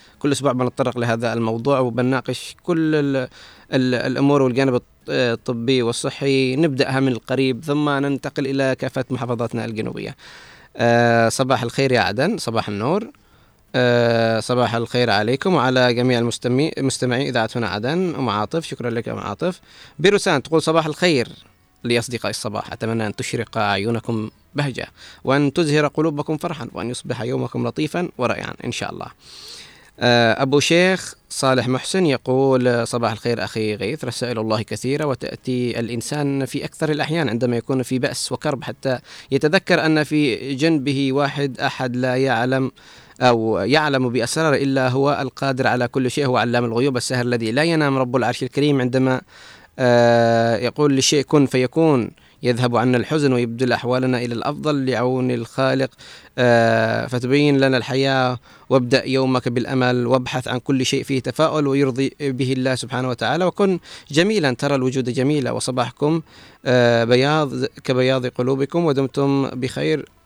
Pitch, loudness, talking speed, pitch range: 130 Hz, -20 LUFS, 140 wpm, 120-140 Hz